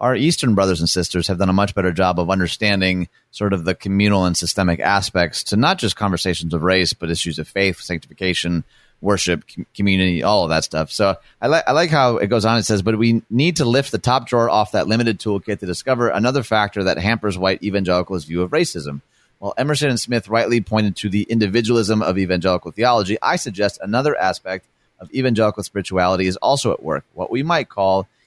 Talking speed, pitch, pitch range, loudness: 210 wpm, 100 Hz, 90-115 Hz, -18 LUFS